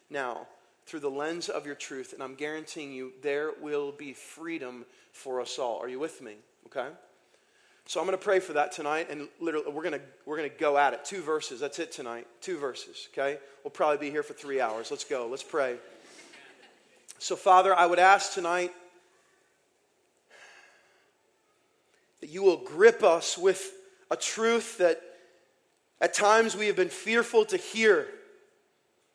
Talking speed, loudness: 165 wpm, -28 LUFS